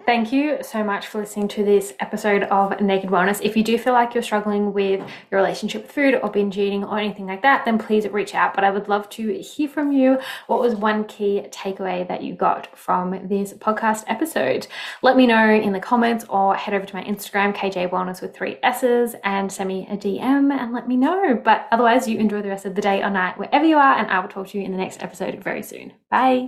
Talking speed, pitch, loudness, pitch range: 245 wpm, 210 Hz, -20 LUFS, 200-240 Hz